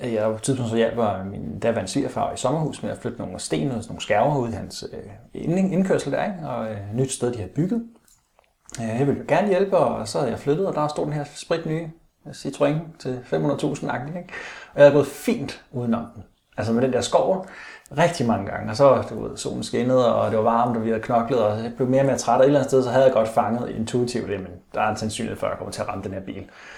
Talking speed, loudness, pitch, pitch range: 260 wpm, -23 LUFS, 125 Hz, 110-145 Hz